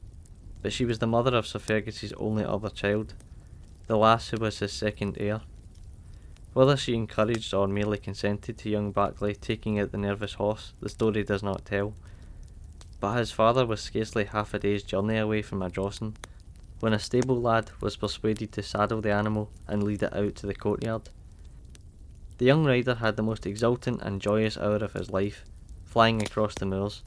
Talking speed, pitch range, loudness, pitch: 185 wpm, 95-110 Hz, -28 LUFS, 105 Hz